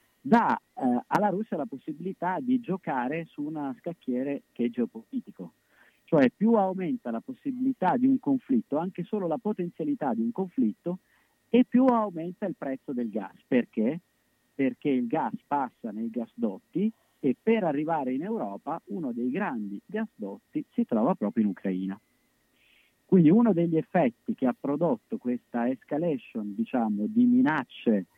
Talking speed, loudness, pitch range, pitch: 145 wpm, -28 LUFS, 160-245 Hz, 210 Hz